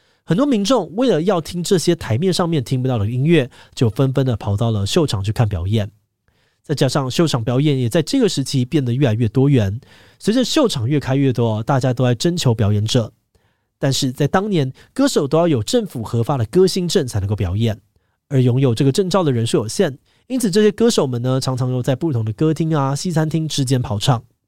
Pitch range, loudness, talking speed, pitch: 115-165 Hz, -18 LUFS, 320 characters per minute, 135 Hz